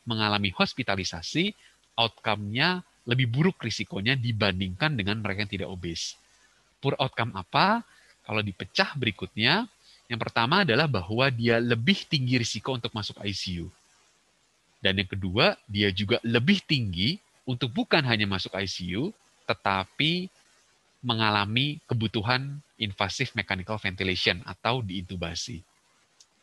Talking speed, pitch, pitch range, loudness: 110 wpm, 115 Hz, 100-135 Hz, -27 LUFS